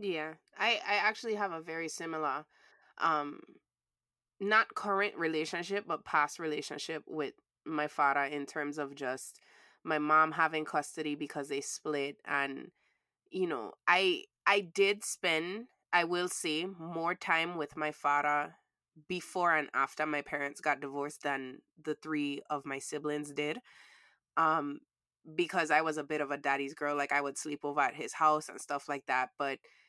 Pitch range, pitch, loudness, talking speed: 145-170 Hz, 155 Hz, -33 LUFS, 165 wpm